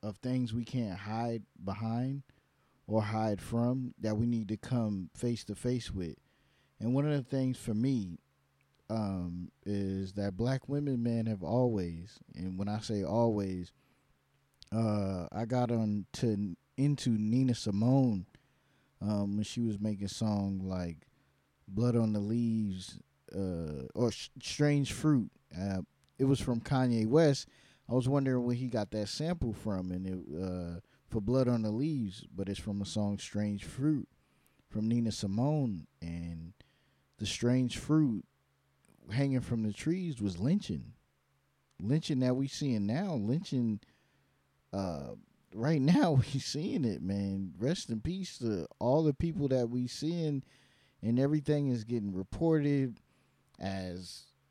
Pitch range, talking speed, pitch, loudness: 95-130 Hz, 150 wpm, 110 Hz, -34 LUFS